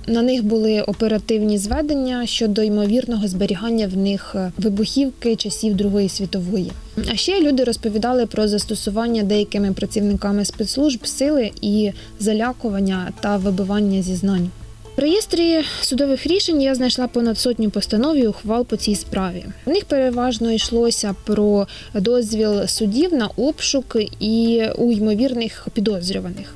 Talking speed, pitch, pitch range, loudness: 125 wpm, 220 Hz, 205-245 Hz, -19 LUFS